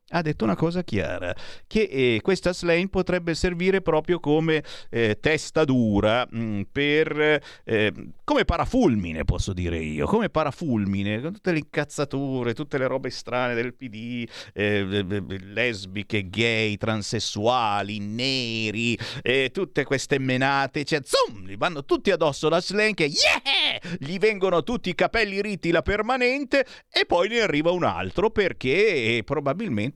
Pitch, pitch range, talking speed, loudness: 145 Hz, 115-180 Hz, 145 wpm, -24 LUFS